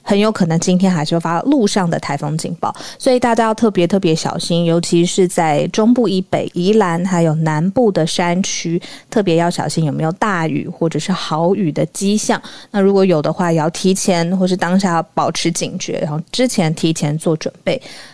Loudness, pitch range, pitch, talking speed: -16 LUFS, 165-195 Hz, 175 Hz, 300 characters per minute